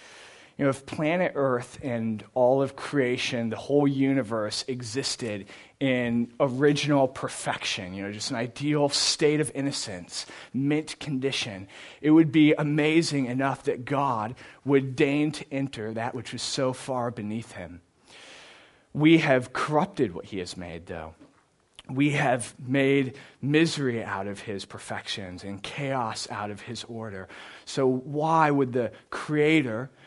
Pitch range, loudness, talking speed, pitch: 110-145 Hz, -26 LUFS, 140 wpm, 130 Hz